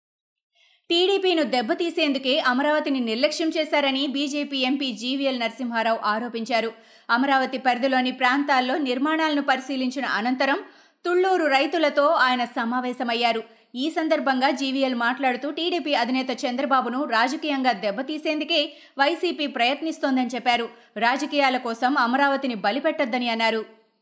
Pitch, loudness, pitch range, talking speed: 270 Hz, -23 LUFS, 245-300 Hz, 90 wpm